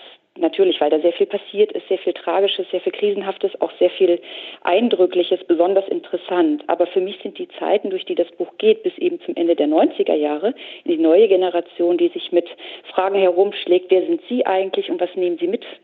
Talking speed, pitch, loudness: 200 wpm, 195 Hz, -19 LUFS